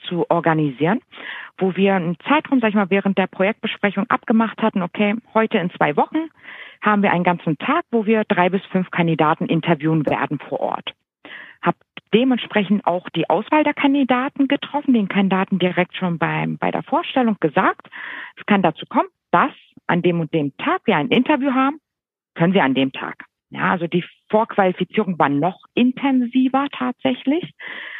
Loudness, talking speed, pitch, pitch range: -19 LUFS, 165 wpm, 205 Hz, 170-255 Hz